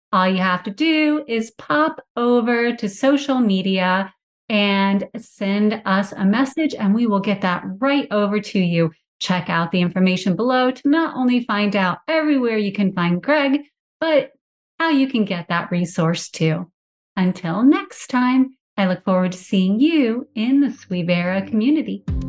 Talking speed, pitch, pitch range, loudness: 165 wpm, 210 Hz, 185-265 Hz, -19 LUFS